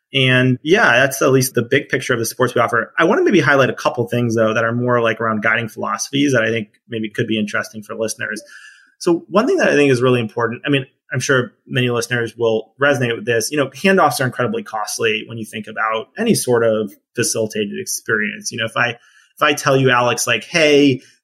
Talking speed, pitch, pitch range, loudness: 235 wpm, 125 Hz, 115-140 Hz, -17 LUFS